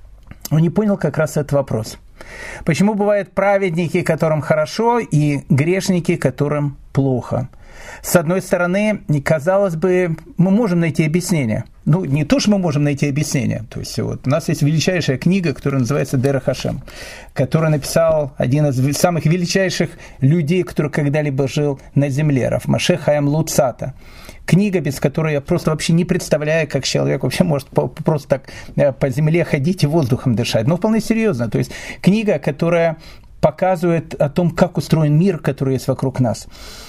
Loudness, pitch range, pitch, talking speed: -17 LUFS, 140-180 Hz, 155 Hz, 160 wpm